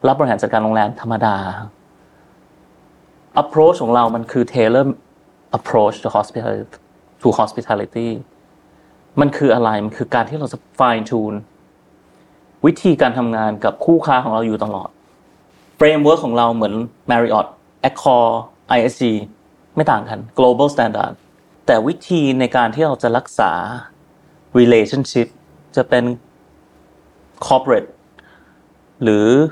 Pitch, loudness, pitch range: 115 Hz, -16 LUFS, 110-130 Hz